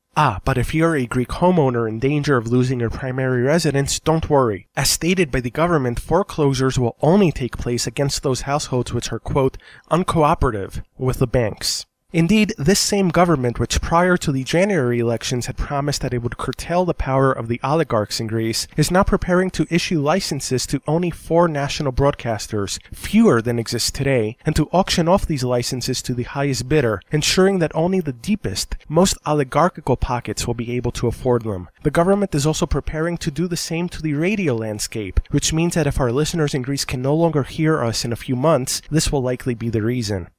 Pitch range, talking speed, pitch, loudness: 120-165 Hz, 200 wpm, 140 Hz, -20 LUFS